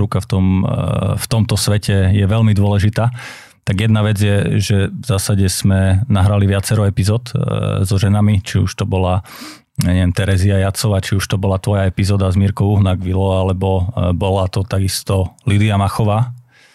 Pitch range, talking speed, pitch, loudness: 95-105 Hz, 160 wpm, 100 Hz, -16 LUFS